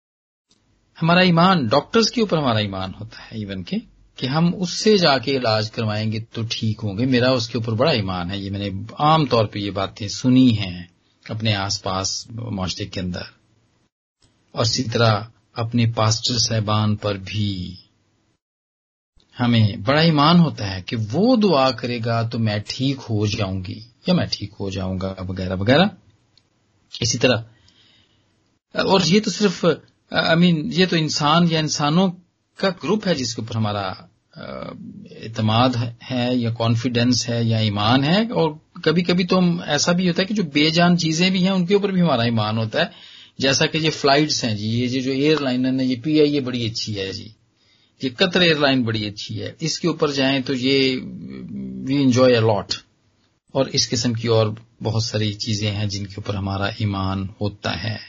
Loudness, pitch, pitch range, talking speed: -20 LUFS, 115 Hz, 105-150 Hz, 170 wpm